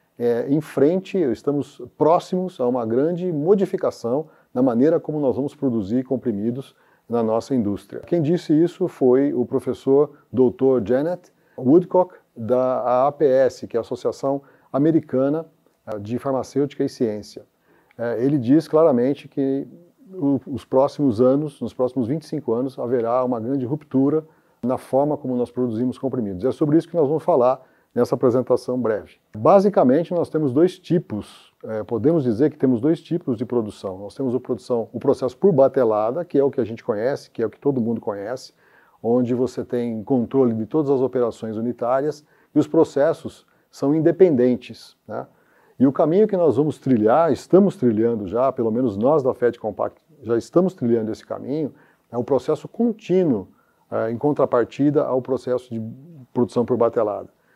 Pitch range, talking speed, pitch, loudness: 120-155 Hz, 165 wpm, 135 Hz, -21 LUFS